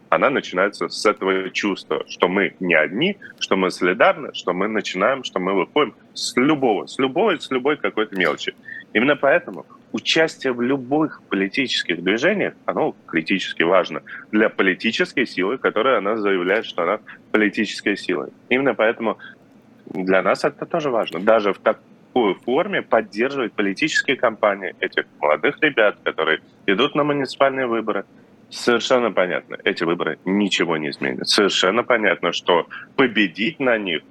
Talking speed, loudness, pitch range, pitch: 145 wpm, -20 LUFS, 95-135 Hz, 105 Hz